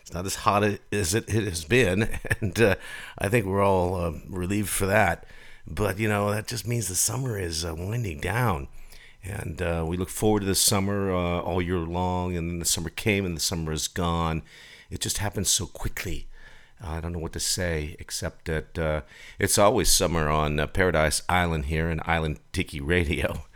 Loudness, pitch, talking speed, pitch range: -26 LUFS, 90 Hz, 205 wpm, 80-100 Hz